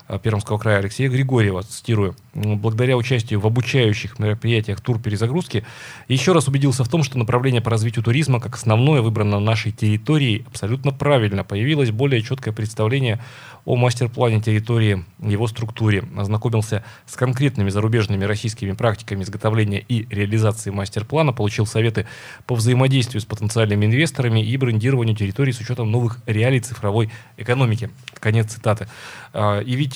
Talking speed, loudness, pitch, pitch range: 135 wpm, -20 LUFS, 115 Hz, 105-125 Hz